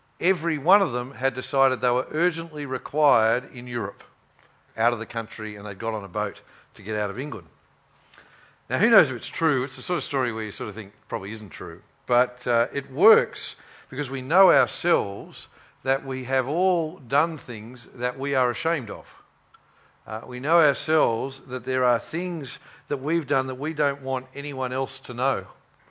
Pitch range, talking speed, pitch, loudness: 120-145 Hz, 195 wpm, 130 Hz, -25 LUFS